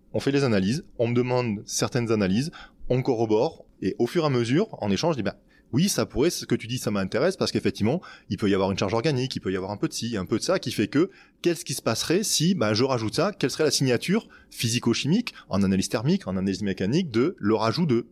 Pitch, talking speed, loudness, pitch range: 120 Hz, 260 wpm, -25 LUFS, 105-145 Hz